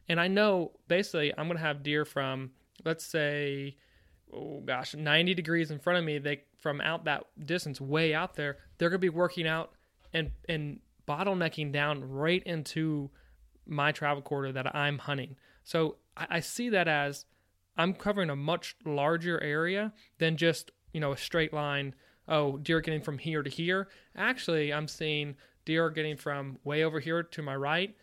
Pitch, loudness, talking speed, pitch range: 155 Hz, -31 LUFS, 180 wpm, 145-170 Hz